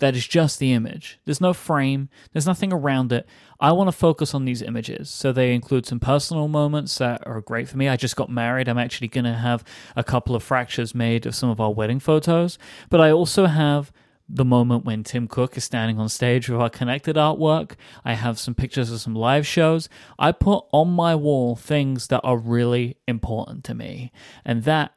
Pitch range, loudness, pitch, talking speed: 120-150 Hz, -21 LUFS, 130 Hz, 215 wpm